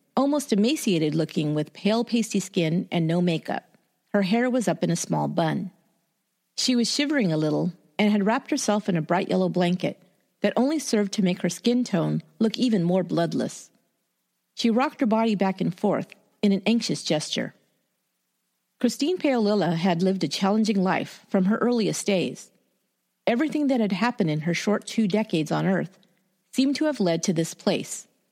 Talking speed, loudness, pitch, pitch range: 180 wpm, -24 LUFS, 205 Hz, 180-230 Hz